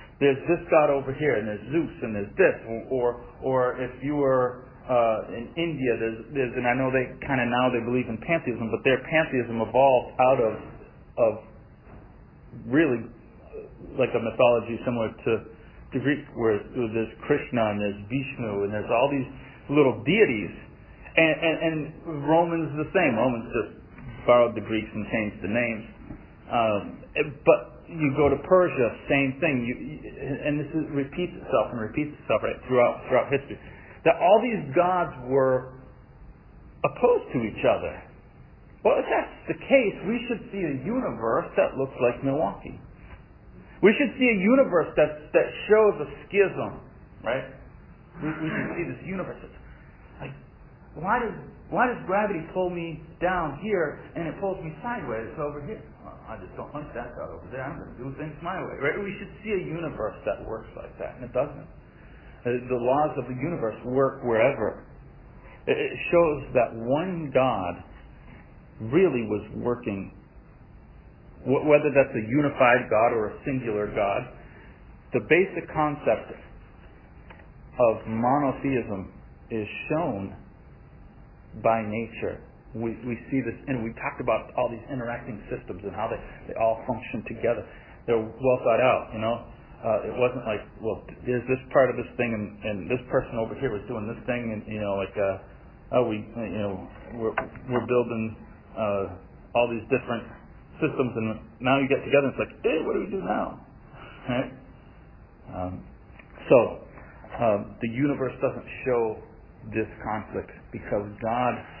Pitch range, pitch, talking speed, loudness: 110-150 Hz, 125 Hz, 165 wpm, -26 LUFS